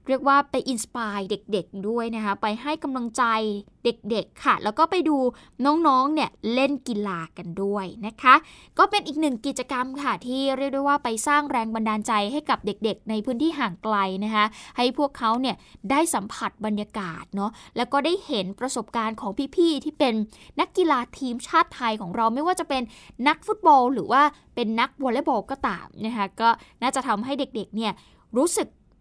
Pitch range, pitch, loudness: 215-280 Hz, 245 Hz, -24 LUFS